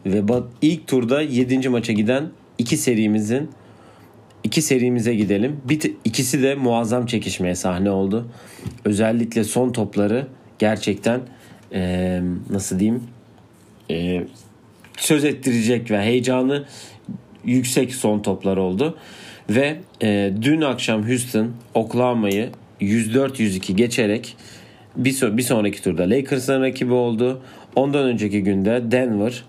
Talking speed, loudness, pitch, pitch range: 100 wpm, -20 LUFS, 115 Hz, 105-130 Hz